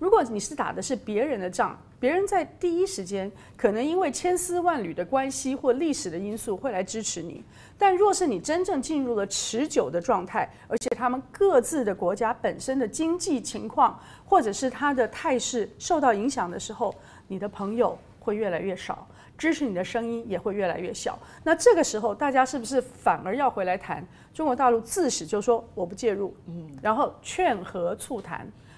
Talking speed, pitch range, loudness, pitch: 290 characters per minute, 205-310 Hz, -26 LUFS, 245 Hz